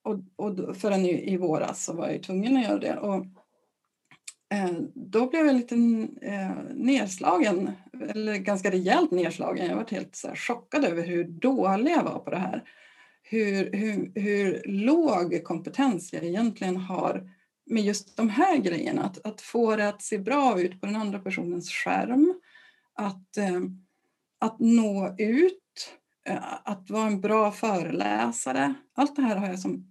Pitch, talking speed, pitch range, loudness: 210 Hz, 155 wpm, 185-245 Hz, -27 LUFS